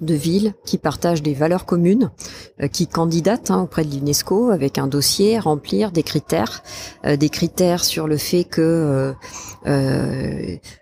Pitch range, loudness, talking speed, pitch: 140-180 Hz, -19 LUFS, 165 wpm, 160 Hz